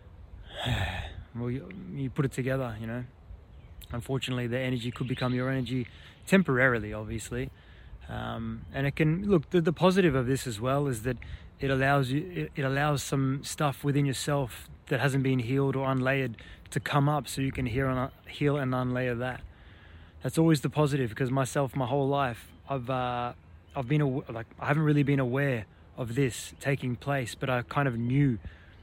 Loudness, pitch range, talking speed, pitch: -29 LUFS, 115-140 Hz, 185 wpm, 130 Hz